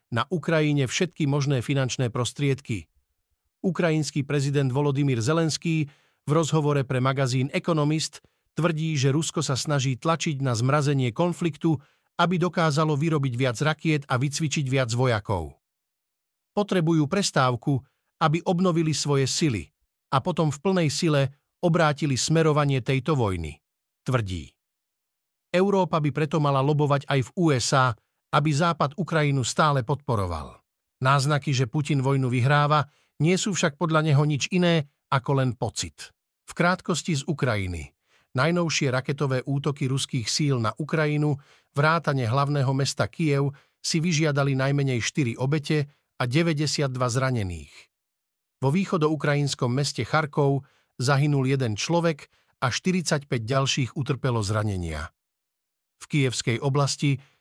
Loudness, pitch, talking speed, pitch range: -24 LUFS, 145 Hz, 120 wpm, 130-160 Hz